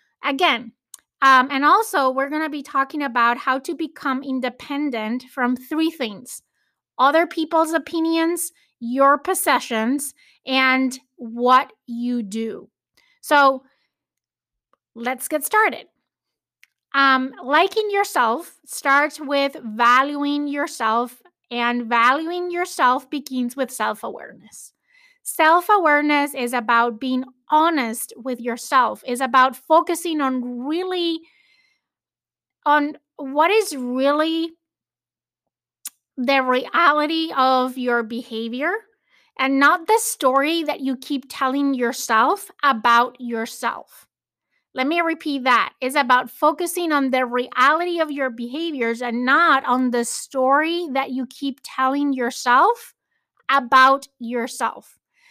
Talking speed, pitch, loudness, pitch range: 110 wpm, 275 Hz, -20 LUFS, 250-320 Hz